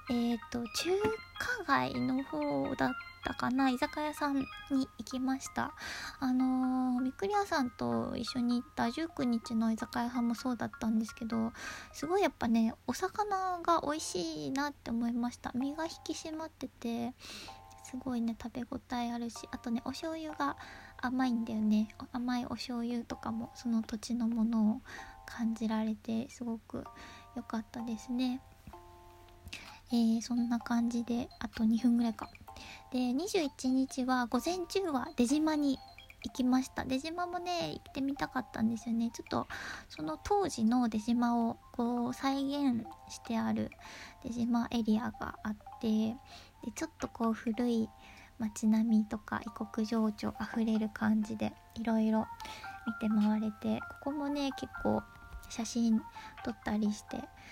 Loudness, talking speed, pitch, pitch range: -34 LUFS, 275 characters per minute, 240 Hz, 225-275 Hz